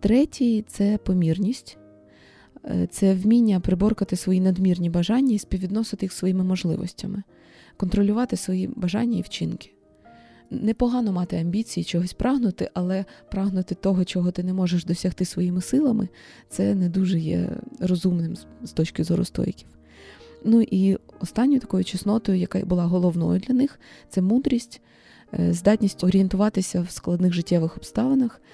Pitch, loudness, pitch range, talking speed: 185 Hz, -23 LUFS, 175-210 Hz, 130 wpm